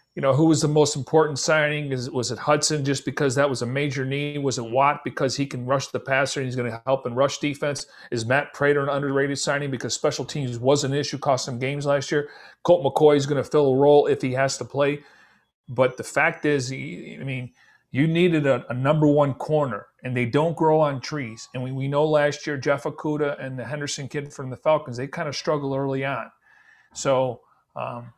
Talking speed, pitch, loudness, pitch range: 230 wpm, 140 Hz, -23 LUFS, 130-150 Hz